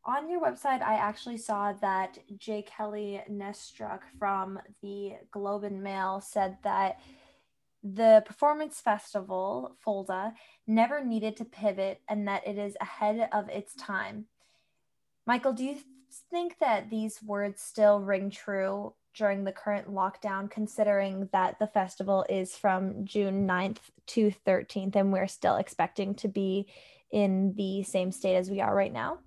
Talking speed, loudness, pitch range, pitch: 150 wpm, -30 LUFS, 195-220 Hz, 205 Hz